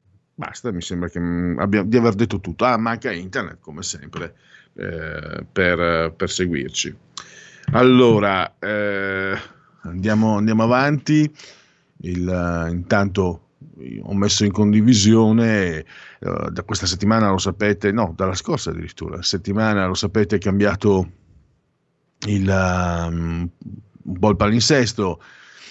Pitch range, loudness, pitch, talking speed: 90-110 Hz, -19 LUFS, 100 Hz, 125 wpm